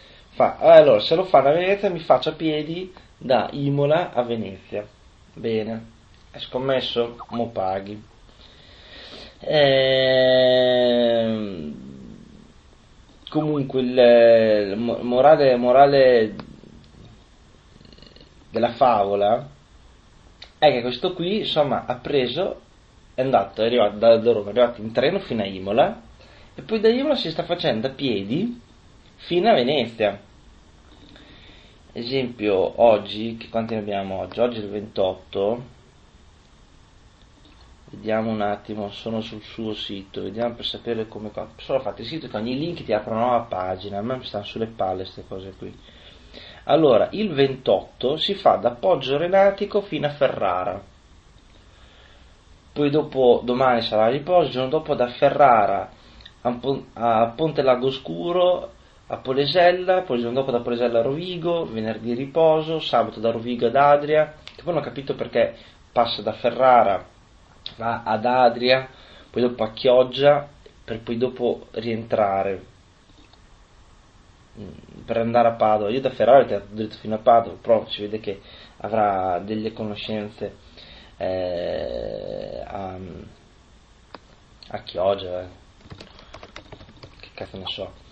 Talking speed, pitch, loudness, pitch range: 130 wpm, 115 Hz, -21 LUFS, 105-135 Hz